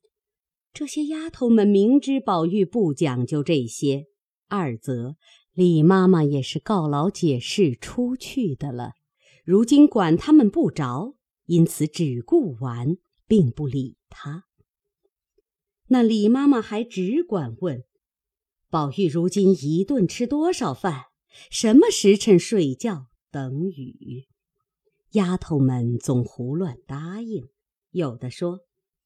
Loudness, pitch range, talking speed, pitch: -21 LUFS, 145-220 Hz, 170 characters per minute, 180 Hz